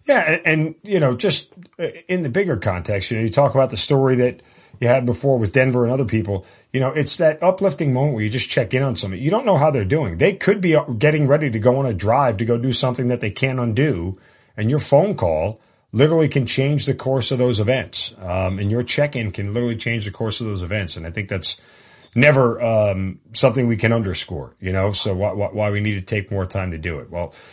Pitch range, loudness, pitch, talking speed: 105-140 Hz, -19 LUFS, 120 Hz, 255 wpm